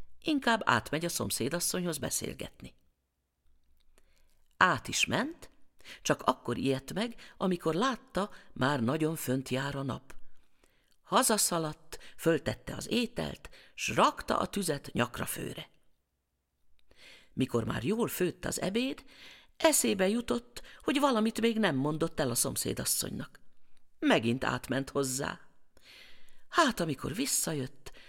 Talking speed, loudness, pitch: 110 wpm, -31 LUFS, 150 Hz